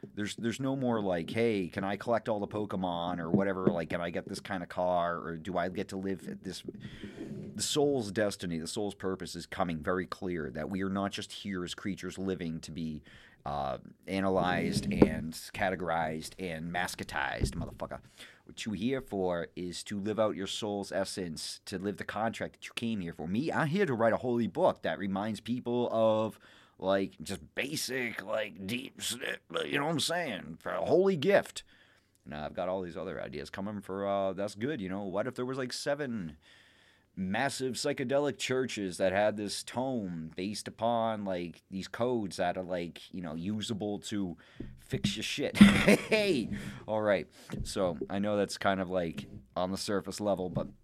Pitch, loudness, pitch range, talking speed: 100 Hz, -33 LUFS, 90-110 Hz, 190 wpm